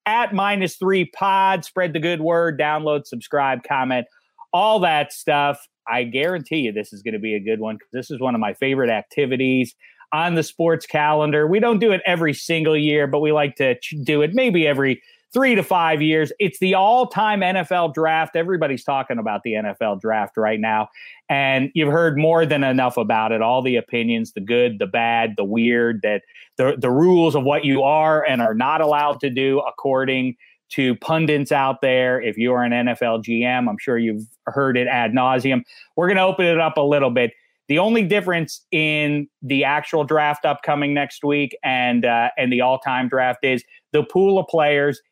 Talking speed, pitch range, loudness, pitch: 195 wpm, 125-165 Hz, -19 LUFS, 145 Hz